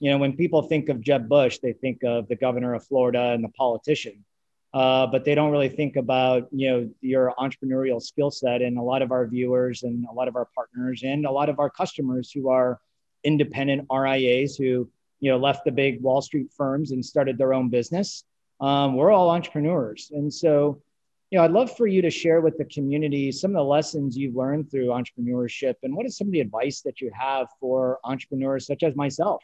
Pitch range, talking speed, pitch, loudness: 125-145 Hz, 220 wpm, 135 Hz, -24 LUFS